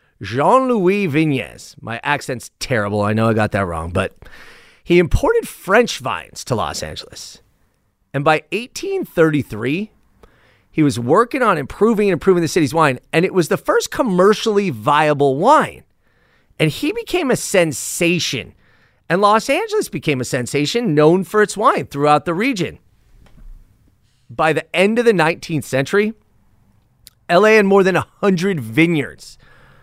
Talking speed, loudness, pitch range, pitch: 145 wpm, -17 LUFS, 125-200 Hz, 155 Hz